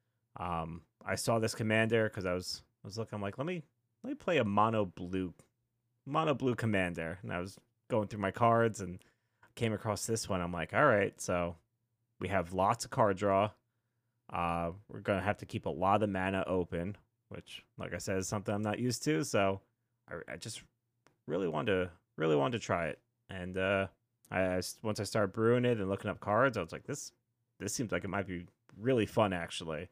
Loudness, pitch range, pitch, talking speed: -34 LUFS, 95-115 Hz, 105 Hz, 215 wpm